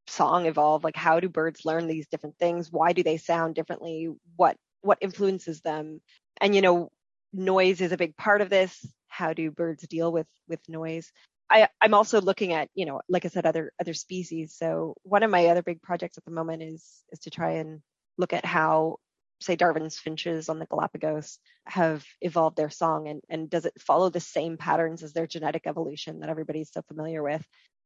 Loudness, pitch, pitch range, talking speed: -26 LUFS, 165 Hz, 160-175 Hz, 210 wpm